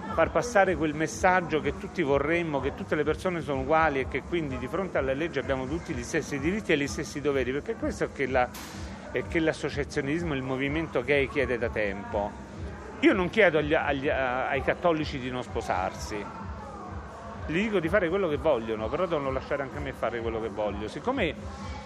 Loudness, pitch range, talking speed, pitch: -28 LUFS, 130-165 Hz, 195 wpm, 145 Hz